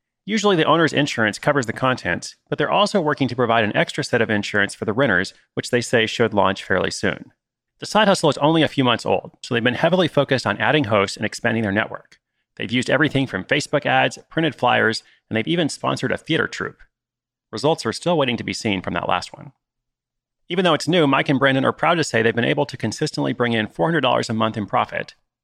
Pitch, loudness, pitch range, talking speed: 125 Hz, -20 LUFS, 110-150 Hz, 230 wpm